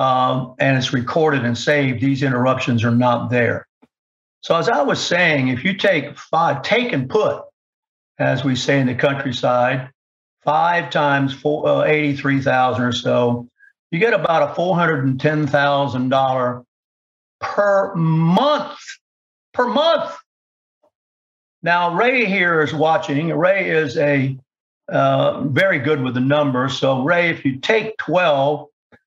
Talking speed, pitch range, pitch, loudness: 145 wpm, 130-175 Hz, 140 Hz, -18 LUFS